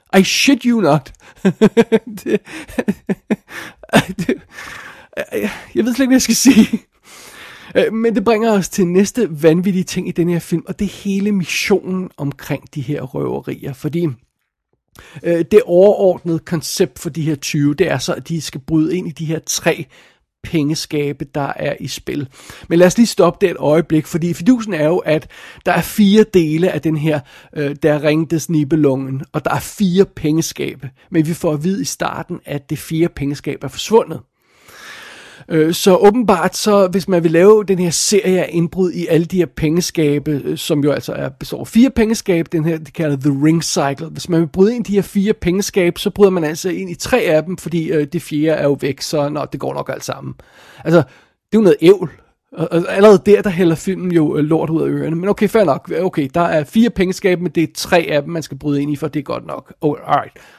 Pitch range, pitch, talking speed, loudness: 155-195 Hz, 170 Hz, 205 wpm, -16 LUFS